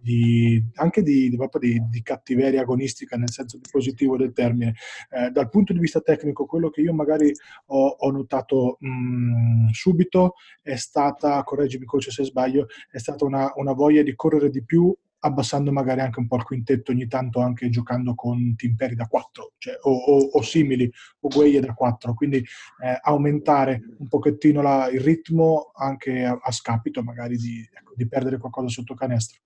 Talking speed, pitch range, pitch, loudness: 180 wpm, 125-145 Hz, 135 Hz, -22 LUFS